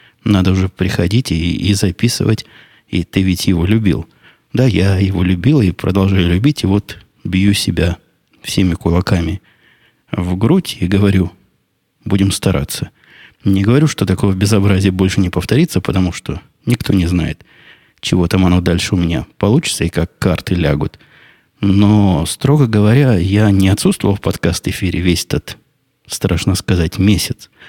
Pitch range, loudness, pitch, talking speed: 90-105 Hz, -15 LUFS, 95 Hz, 145 wpm